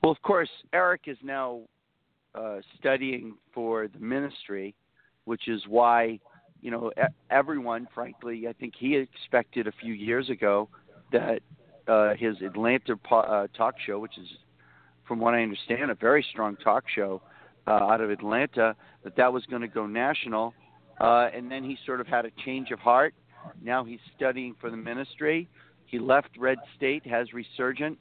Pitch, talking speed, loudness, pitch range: 120 Hz, 165 wpm, -27 LUFS, 110-130 Hz